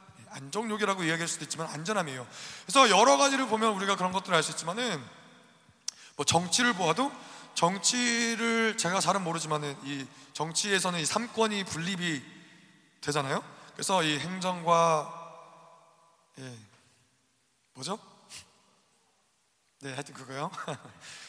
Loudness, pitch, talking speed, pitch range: -28 LUFS, 165 Hz, 275 characters per minute, 145-200 Hz